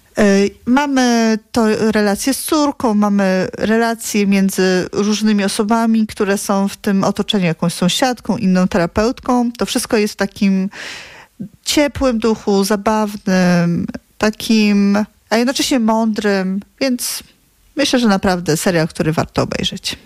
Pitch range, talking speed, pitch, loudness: 195-230 Hz, 115 wpm, 215 Hz, -16 LUFS